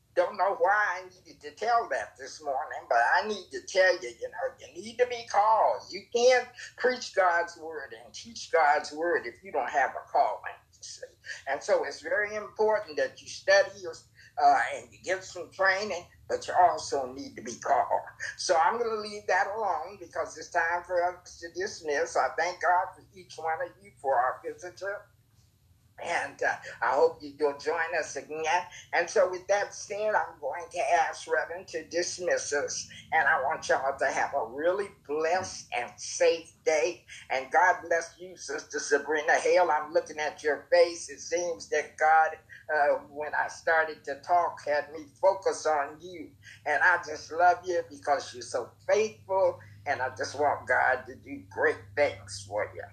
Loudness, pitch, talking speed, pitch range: -28 LUFS, 180 Hz, 185 wpm, 155-215 Hz